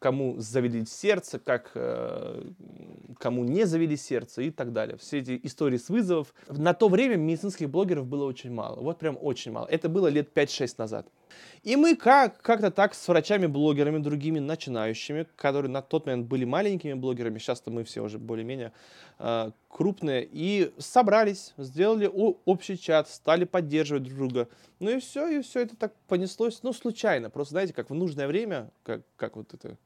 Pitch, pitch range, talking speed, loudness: 160 Hz, 130-200 Hz, 175 wpm, -27 LUFS